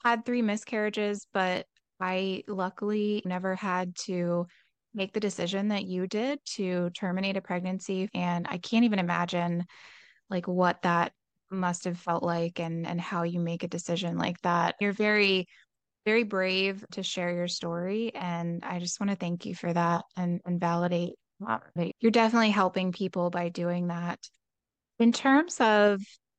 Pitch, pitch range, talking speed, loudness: 185 Hz, 175-205 Hz, 160 wpm, -29 LUFS